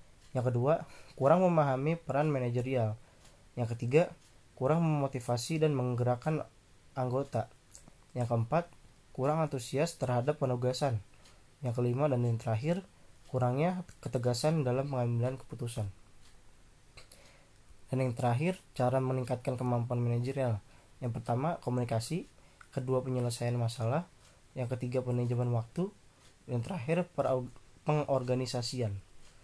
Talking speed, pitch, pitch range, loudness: 100 wpm, 125 Hz, 120-140 Hz, -33 LUFS